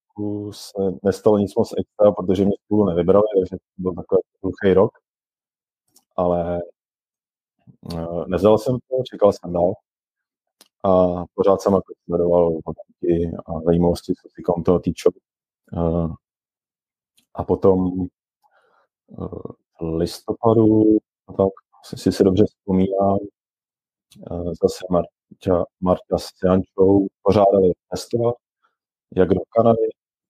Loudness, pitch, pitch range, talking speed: -20 LUFS, 95 Hz, 85-105 Hz, 105 wpm